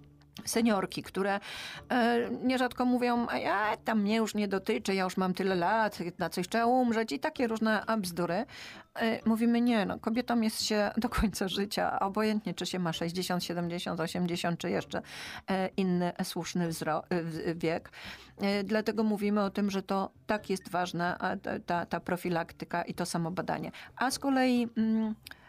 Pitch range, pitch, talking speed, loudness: 175-225 Hz, 200 Hz, 150 wpm, -31 LUFS